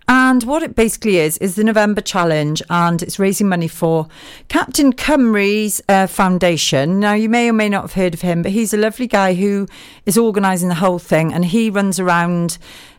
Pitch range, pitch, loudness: 175-215 Hz, 195 Hz, -15 LUFS